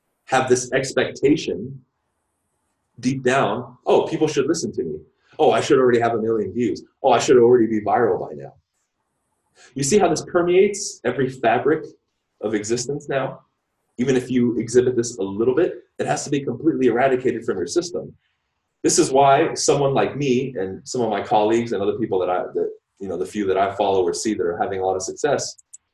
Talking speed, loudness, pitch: 200 wpm, -20 LUFS, 130 Hz